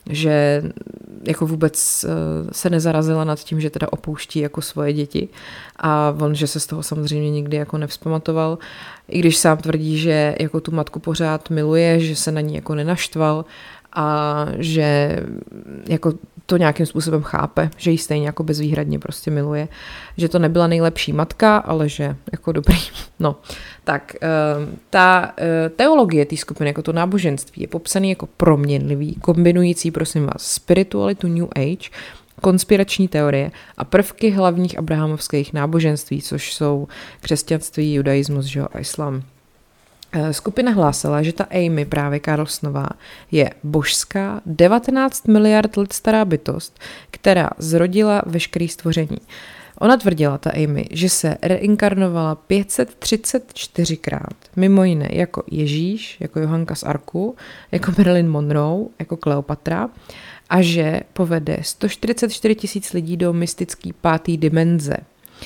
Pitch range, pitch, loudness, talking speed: 150-180 Hz, 160 Hz, -19 LUFS, 130 wpm